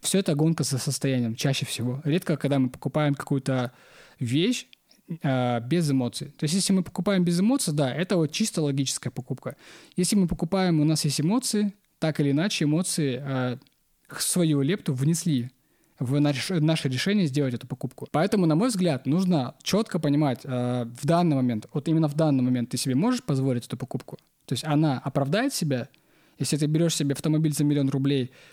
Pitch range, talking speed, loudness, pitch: 135-170 Hz, 180 wpm, -25 LUFS, 150 Hz